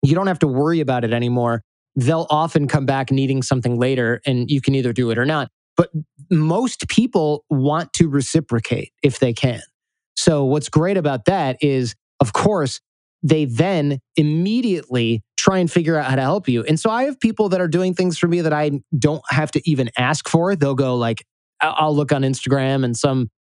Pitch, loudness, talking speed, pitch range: 150 Hz, -19 LUFS, 200 wpm, 130-165 Hz